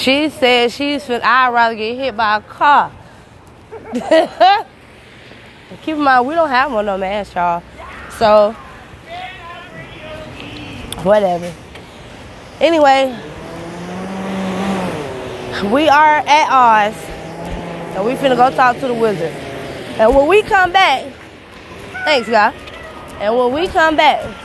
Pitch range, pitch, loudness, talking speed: 200-300 Hz, 245 Hz, -14 LUFS, 120 wpm